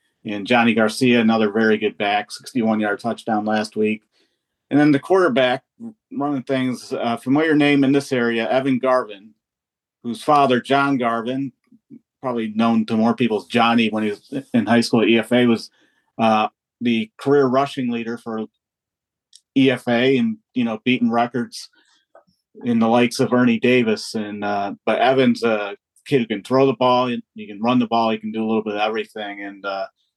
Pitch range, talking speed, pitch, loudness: 110-130 Hz, 180 wpm, 120 Hz, -19 LUFS